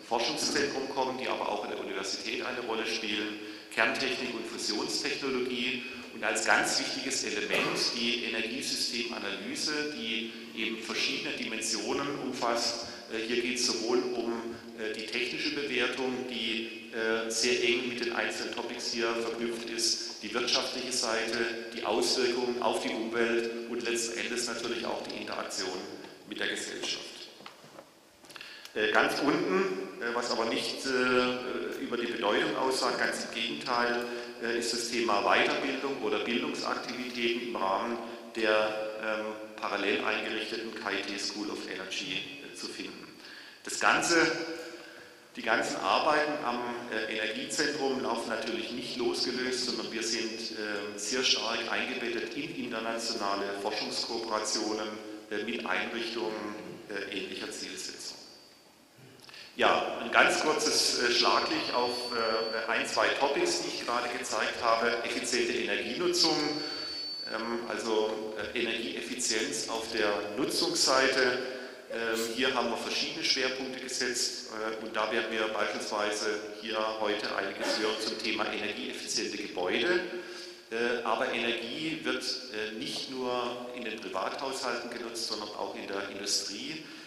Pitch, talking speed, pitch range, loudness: 115 Hz, 120 wpm, 110-125 Hz, -31 LUFS